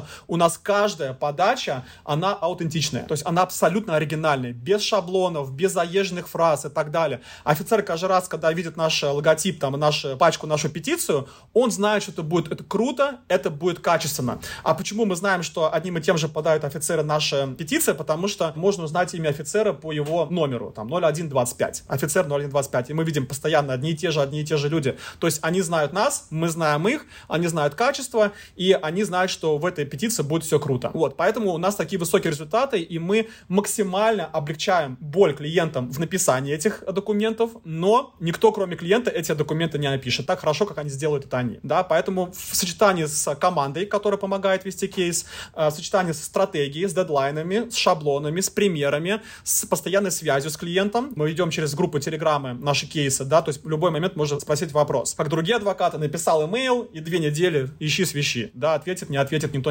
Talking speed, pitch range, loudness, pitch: 190 wpm, 150-195 Hz, -23 LUFS, 165 Hz